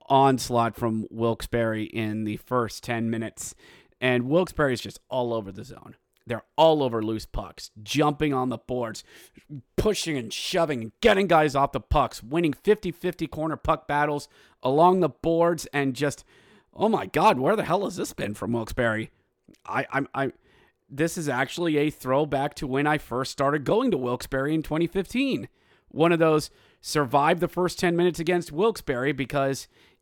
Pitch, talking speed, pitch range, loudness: 145 Hz, 165 wpm, 120-165 Hz, -25 LUFS